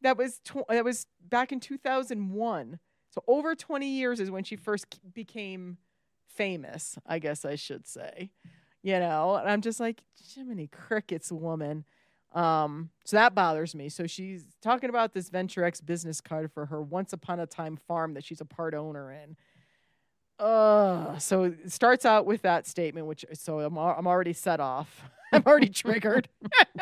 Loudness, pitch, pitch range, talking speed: -28 LUFS, 180 Hz, 160-220 Hz, 175 wpm